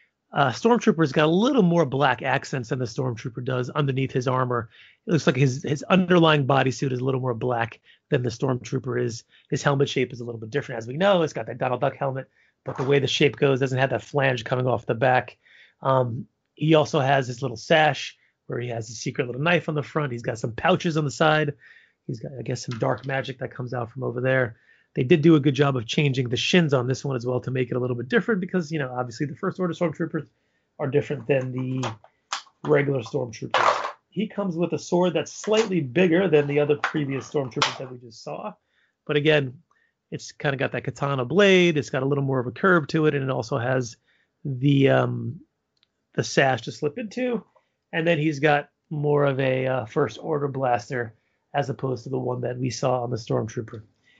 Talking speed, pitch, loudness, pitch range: 225 wpm, 140 Hz, -24 LUFS, 125-155 Hz